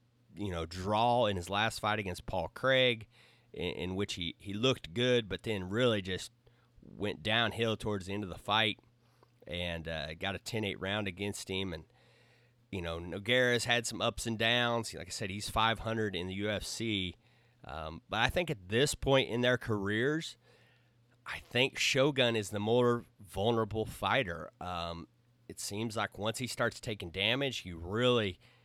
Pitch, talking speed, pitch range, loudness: 110 Hz, 175 wpm, 100-120 Hz, -33 LUFS